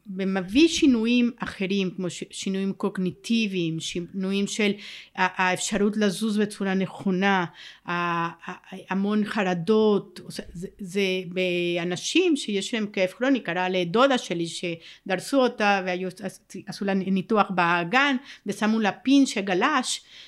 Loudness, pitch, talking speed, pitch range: -24 LUFS, 195 Hz, 100 wpm, 185-215 Hz